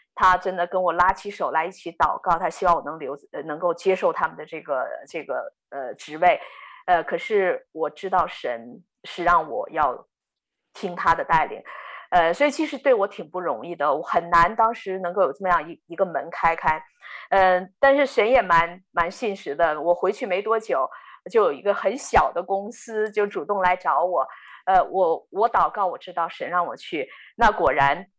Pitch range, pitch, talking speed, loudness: 170-225 Hz, 185 Hz, 270 characters per minute, -23 LUFS